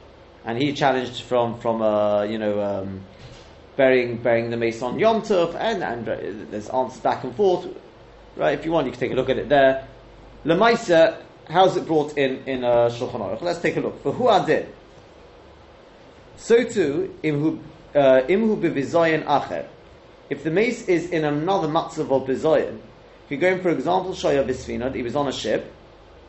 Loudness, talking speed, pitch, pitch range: -22 LUFS, 170 wpm, 135 Hz, 115-165 Hz